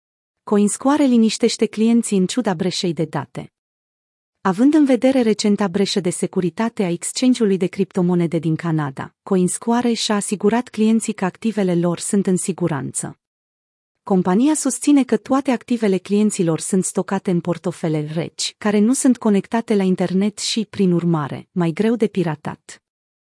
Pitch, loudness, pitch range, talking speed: 200 Hz, -19 LUFS, 175-225 Hz, 140 wpm